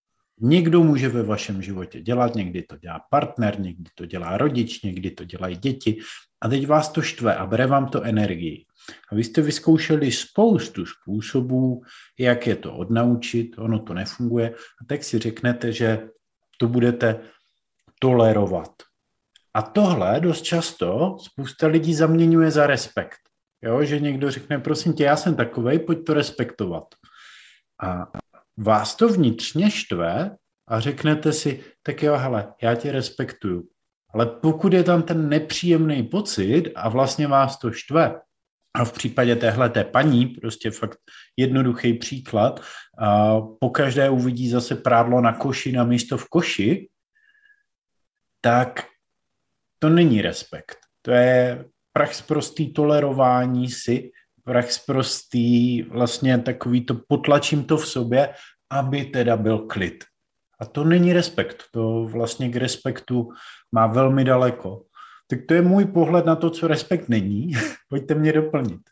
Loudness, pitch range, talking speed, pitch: -21 LUFS, 115-150 Hz, 145 wpm, 125 Hz